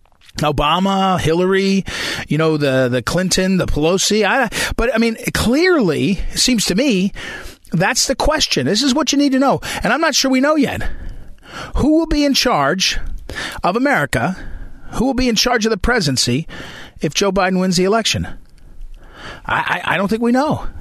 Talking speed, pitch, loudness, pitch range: 180 wpm, 195 Hz, -16 LUFS, 155-255 Hz